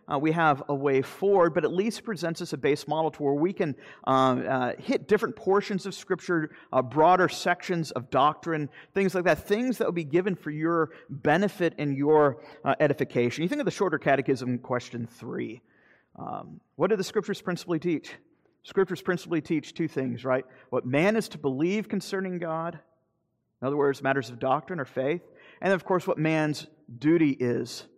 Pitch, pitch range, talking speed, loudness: 160 Hz, 140-180 Hz, 190 wpm, -27 LUFS